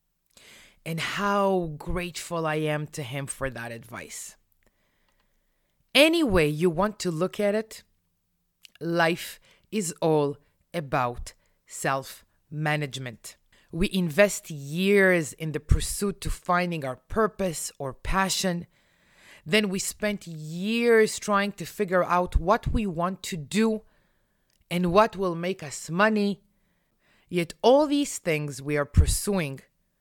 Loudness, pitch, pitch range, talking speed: -26 LUFS, 175 Hz, 145-200 Hz, 120 wpm